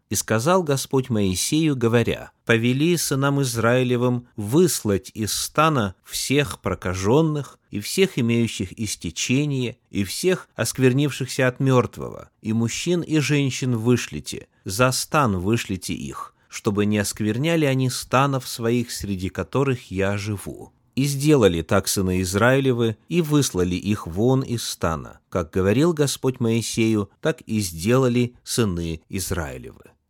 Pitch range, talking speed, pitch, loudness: 100-135 Hz, 120 wpm, 120 Hz, -22 LUFS